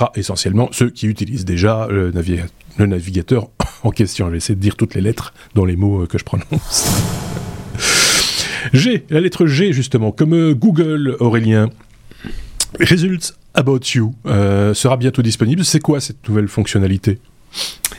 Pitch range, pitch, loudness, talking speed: 100-135 Hz, 115 Hz, -16 LUFS, 145 wpm